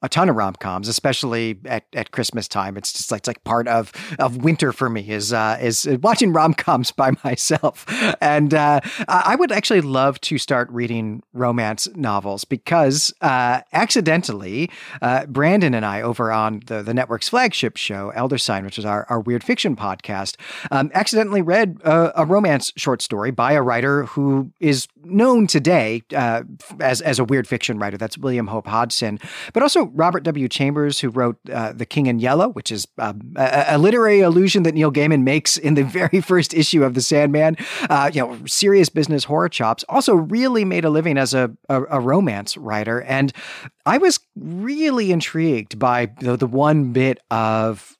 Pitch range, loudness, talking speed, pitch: 115-165 Hz, -18 LUFS, 185 wpm, 135 Hz